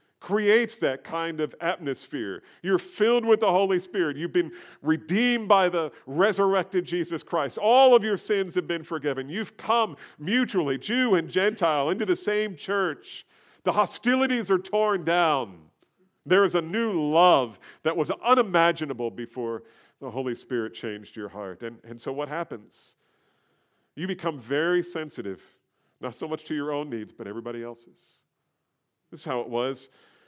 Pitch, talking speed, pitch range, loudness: 170 Hz, 160 wpm, 140-205 Hz, -25 LUFS